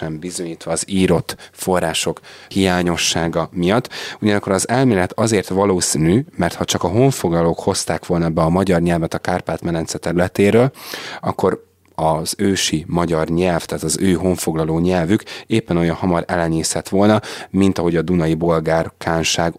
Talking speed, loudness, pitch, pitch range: 140 wpm, -18 LUFS, 90 Hz, 85-100 Hz